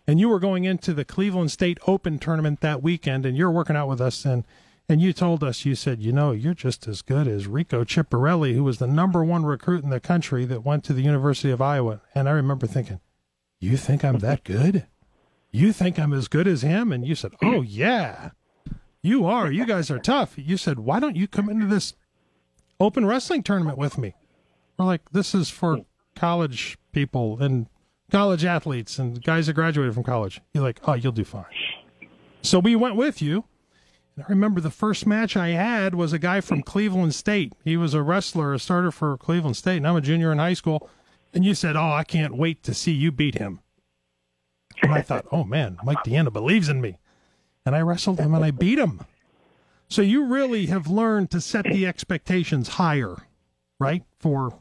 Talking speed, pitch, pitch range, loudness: 210 wpm, 155 Hz, 130-180 Hz, -23 LUFS